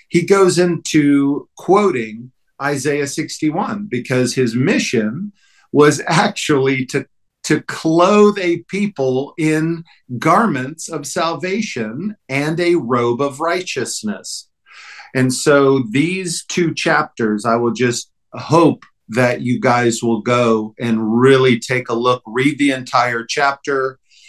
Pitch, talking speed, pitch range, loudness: 140 Hz, 120 wpm, 125-170 Hz, -16 LUFS